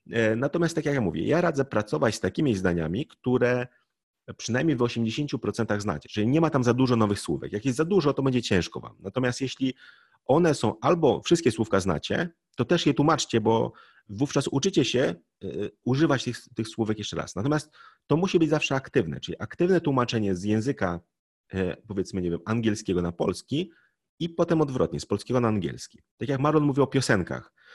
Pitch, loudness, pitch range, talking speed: 125 Hz, -26 LUFS, 105-145 Hz, 180 wpm